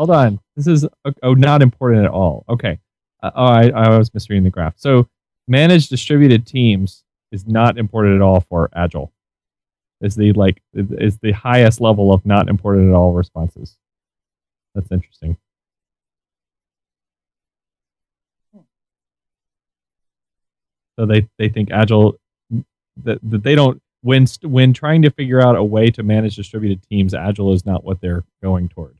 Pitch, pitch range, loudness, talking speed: 105 Hz, 95-120 Hz, -15 LUFS, 150 wpm